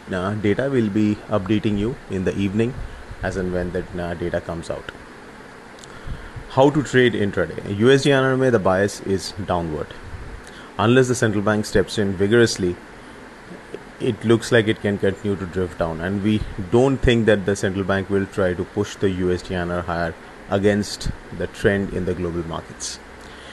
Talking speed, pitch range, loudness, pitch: 165 wpm, 90-110 Hz, -21 LUFS, 100 Hz